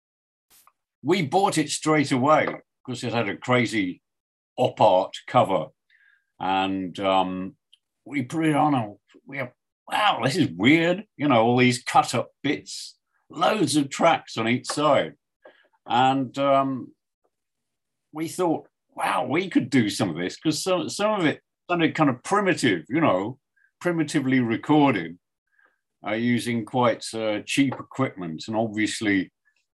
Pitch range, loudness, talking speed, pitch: 110-155 Hz, -23 LUFS, 145 wpm, 130 Hz